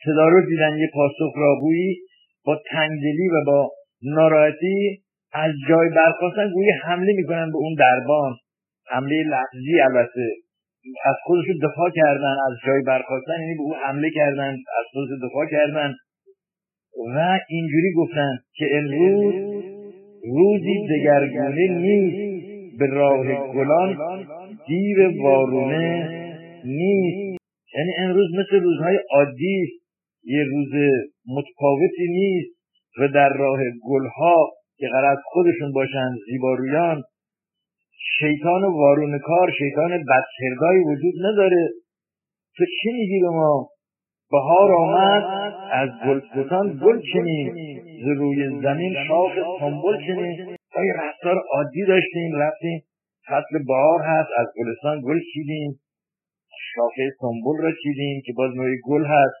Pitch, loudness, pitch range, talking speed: 160 Hz, -20 LUFS, 140-185 Hz, 115 wpm